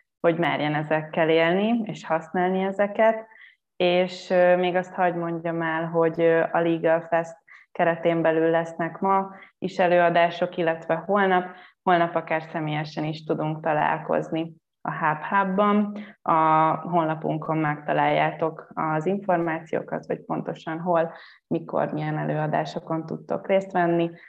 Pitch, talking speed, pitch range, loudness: 170 Hz, 120 wpm, 160-180 Hz, -24 LUFS